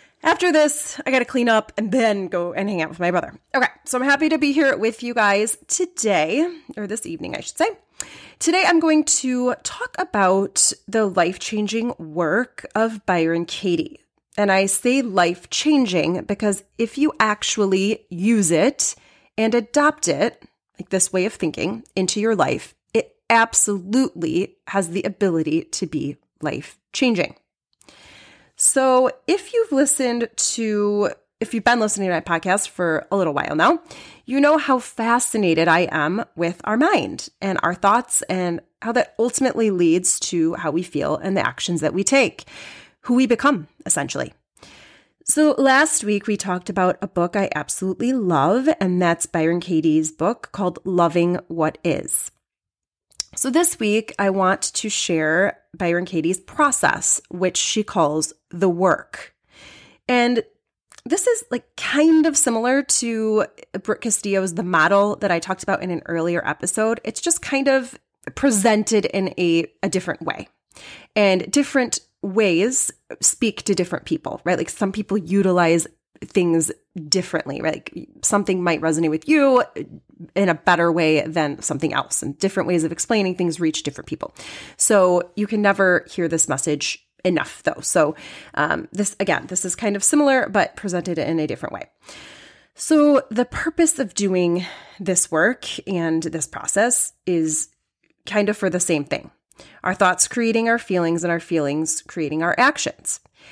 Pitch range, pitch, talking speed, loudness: 175-245 Hz, 200 Hz, 160 wpm, -20 LUFS